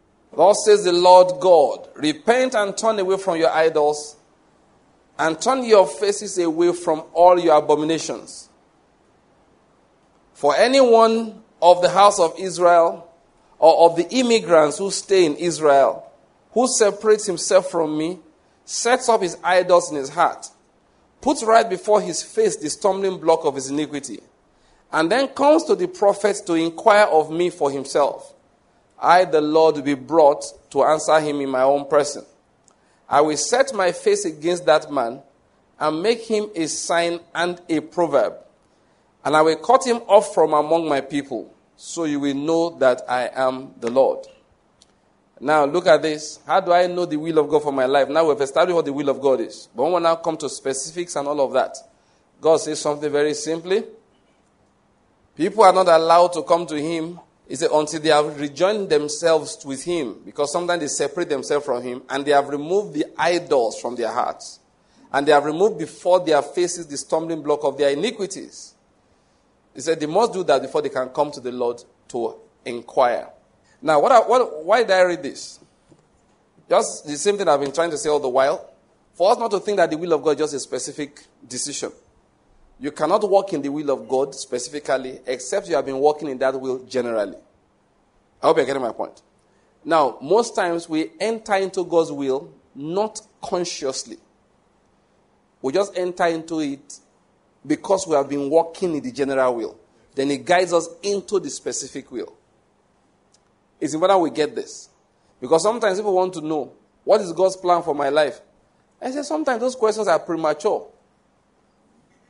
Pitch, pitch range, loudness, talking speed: 165 Hz, 145-190 Hz, -19 LUFS, 180 wpm